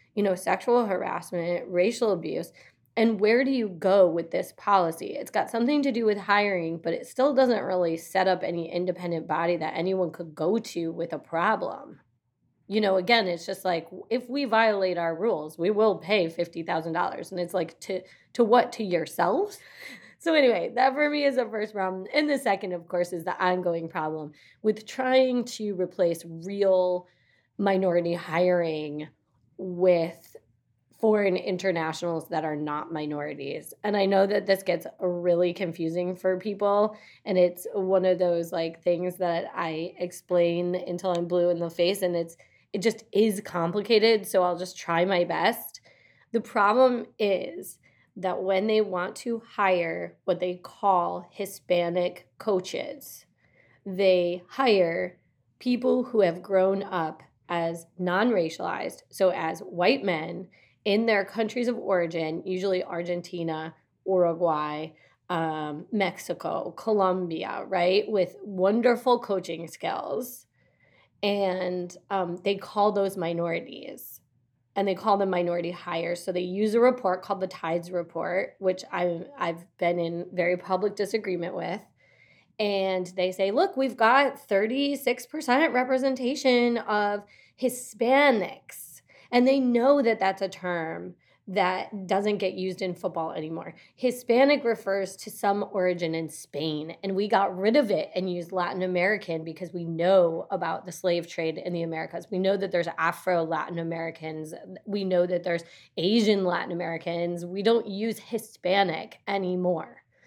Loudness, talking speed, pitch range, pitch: -26 LUFS, 150 wpm, 170-210 Hz, 185 Hz